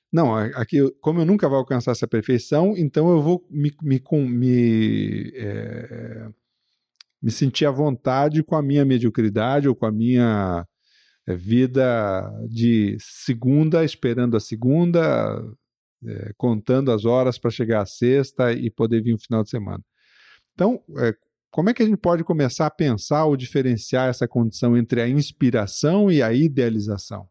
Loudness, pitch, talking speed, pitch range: -21 LUFS, 125 Hz, 155 wpm, 115-145 Hz